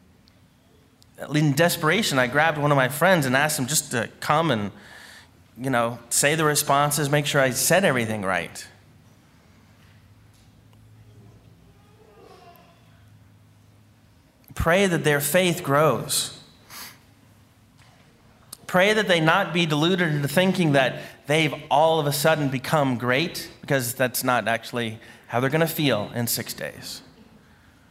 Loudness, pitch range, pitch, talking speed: -22 LUFS, 115-155 Hz, 130 Hz, 125 wpm